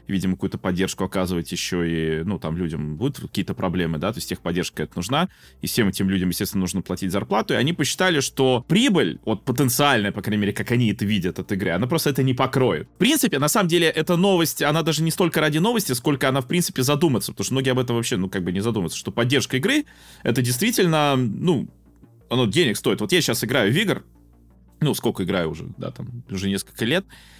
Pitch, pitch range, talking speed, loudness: 120 Hz, 95-145 Hz, 220 wpm, -22 LUFS